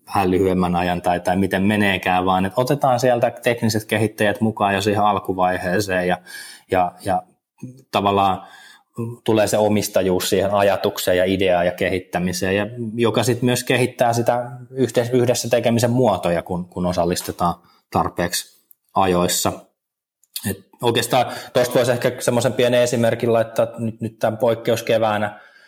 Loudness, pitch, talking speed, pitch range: -19 LUFS, 105 Hz, 130 wpm, 90-120 Hz